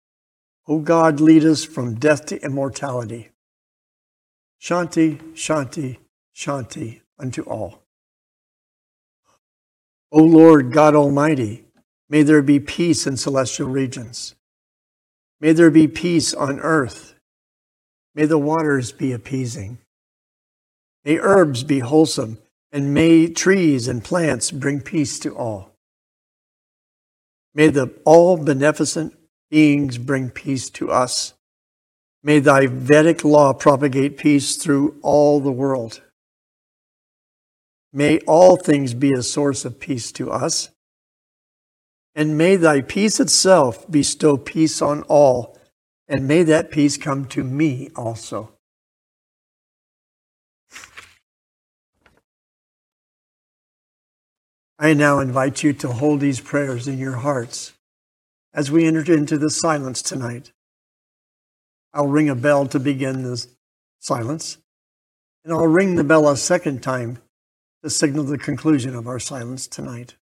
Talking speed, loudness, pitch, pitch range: 115 wpm, -17 LUFS, 145 Hz, 130-155 Hz